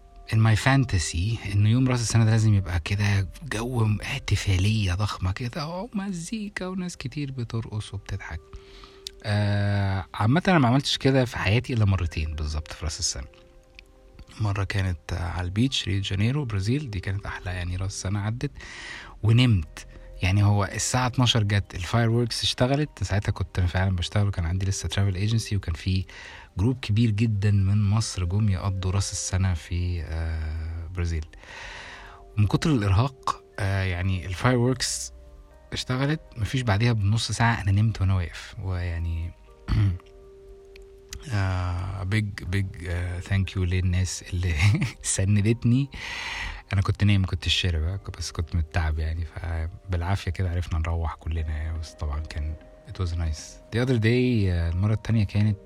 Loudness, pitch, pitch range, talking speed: -26 LUFS, 100 Hz, 90-115 Hz, 135 wpm